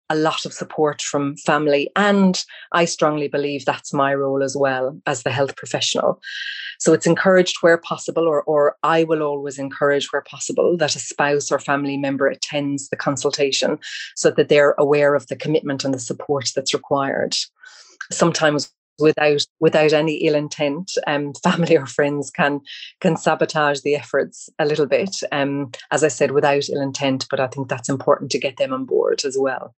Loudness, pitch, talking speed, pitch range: -19 LUFS, 145 Hz, 180 wpm, 140-160 Hz